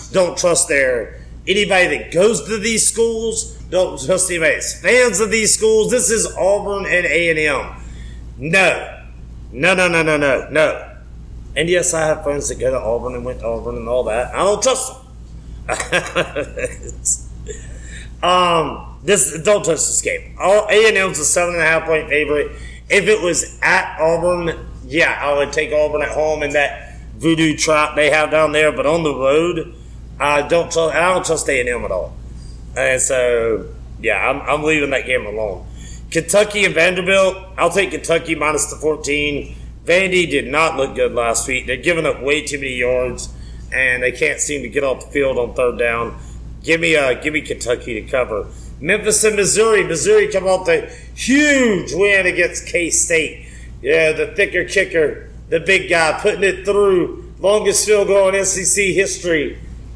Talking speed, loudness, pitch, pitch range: 180 wpm, -16 LUFS, 160 Hz, 130-195 Hz